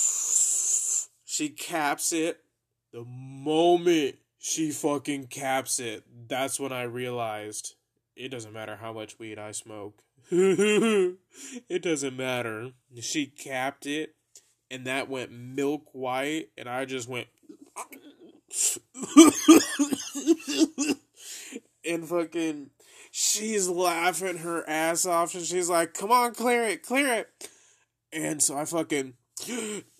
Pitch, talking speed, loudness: 160 Hz, 110 wpm, -26 LUFS